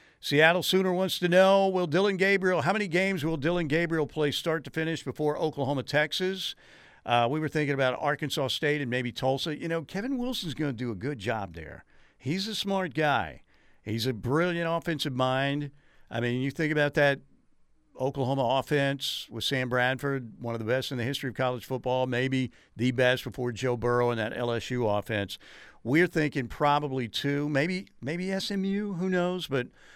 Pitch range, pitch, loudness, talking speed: 125-170 Hz, 145 Hz, -28 LUFS, 185 wpm